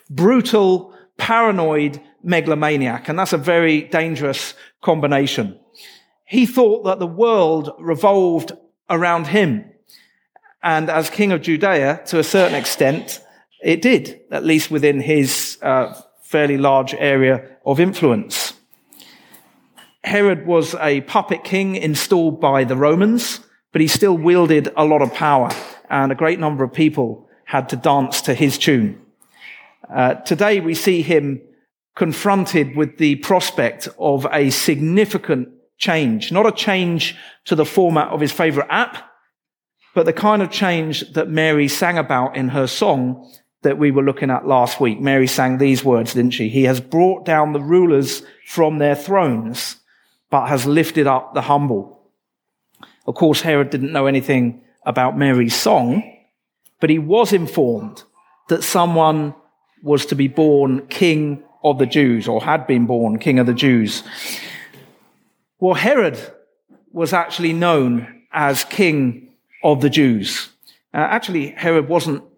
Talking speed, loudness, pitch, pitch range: 145 wpm, -17 LUFS, 155 Hz, 140-175 Hz